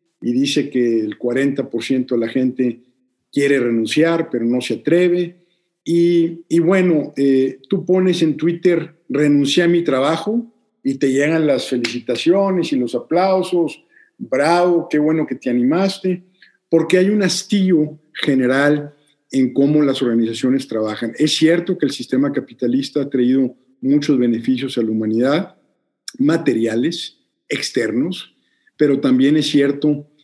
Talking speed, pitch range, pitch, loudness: 135 wpm, 130-170 Hz, 145 Hz, -17 LUFS